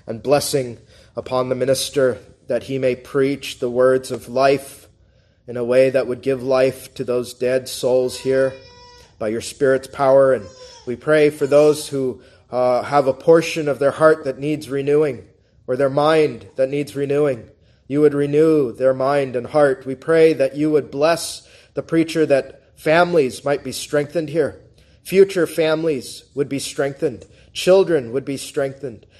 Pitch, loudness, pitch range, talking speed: 135 Hz, -19 LUFS, 125-150 Hz, 165 wpm